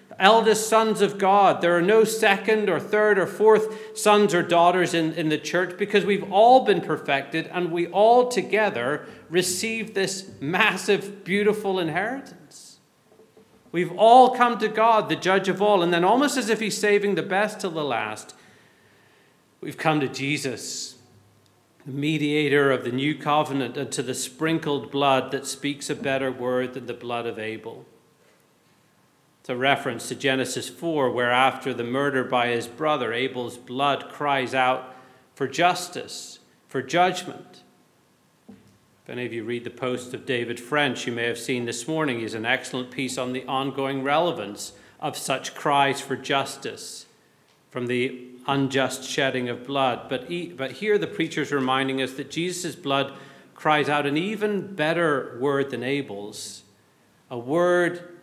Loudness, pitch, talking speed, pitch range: -23 LUFS, 145 Hz, 160 wpm, 130-180 Hz